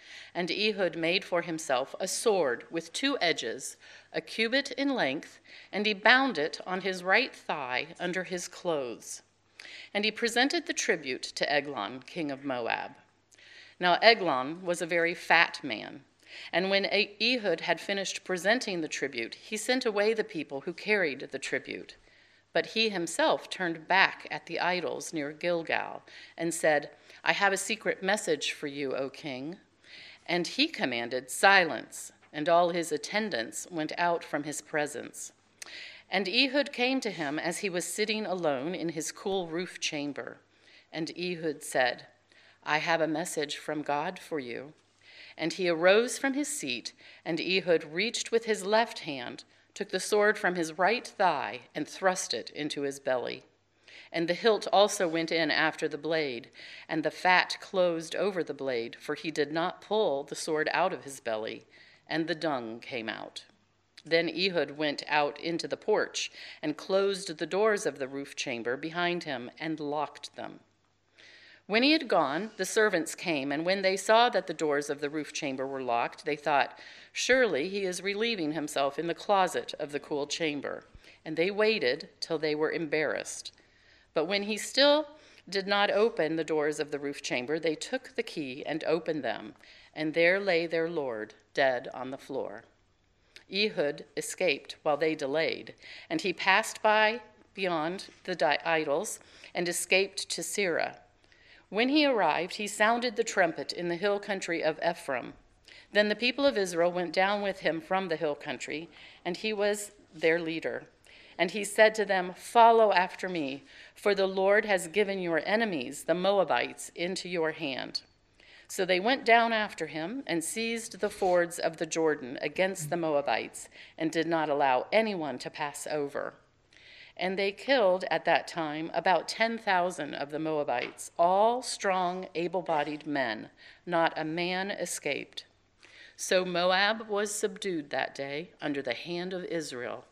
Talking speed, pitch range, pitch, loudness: 165 wpm, 155-205 Hz, 175 Hz, -29 LUFS